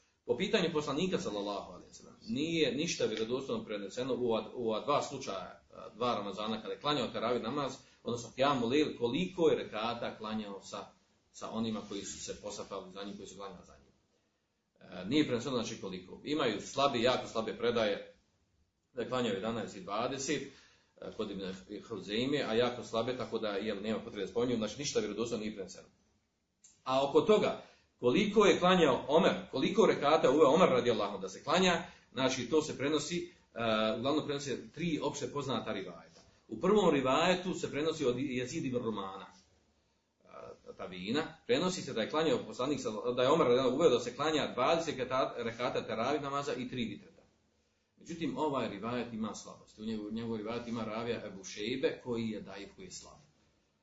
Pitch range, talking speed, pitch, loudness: 110-155 Hz, 165 wpm, 125 Hz, -33 LUFS